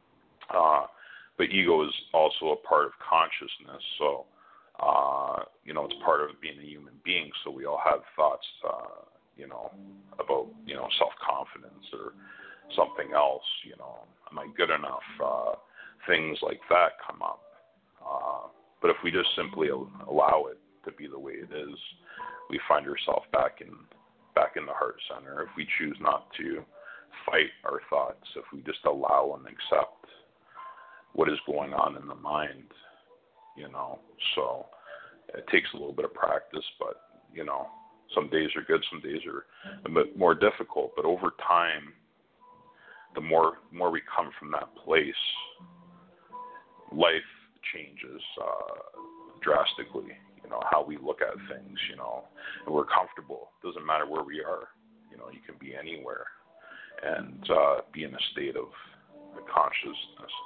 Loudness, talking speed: -29 LUFS, 165 wpm